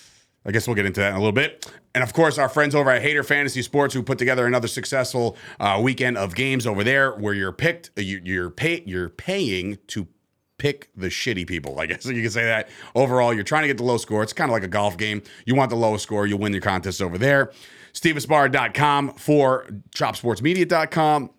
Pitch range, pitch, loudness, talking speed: 105-140 Hz, 125 Hz, -22 LUFS, 220 wpm